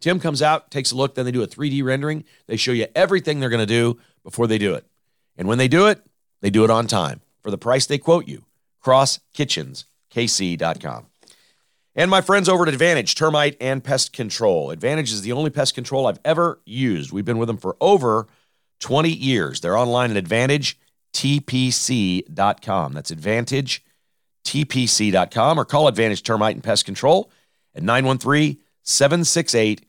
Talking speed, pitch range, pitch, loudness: 170 wpm, 110-150 Hz, 130 Hz, -19 LUFS